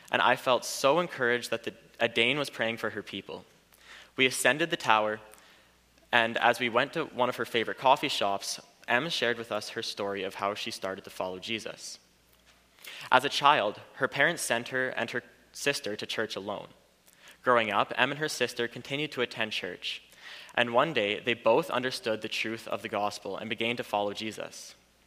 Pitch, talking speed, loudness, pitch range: 115 Hz, 195 wpm, -29 LUFS, 105-120 Hz